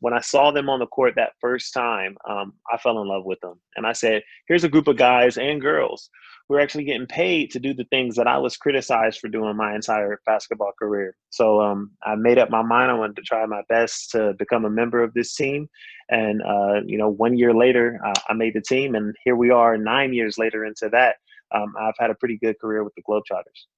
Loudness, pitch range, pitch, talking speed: -21 LUFS, 105-125 Hz, 115 Hz, 245 wpm